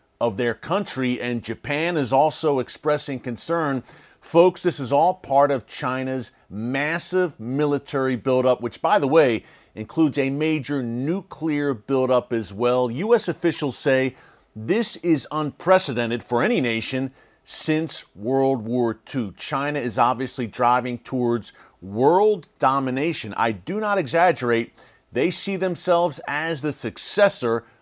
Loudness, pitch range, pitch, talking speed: -22 LUFS, 120-165 Hz, 135 Hz, 130 wpm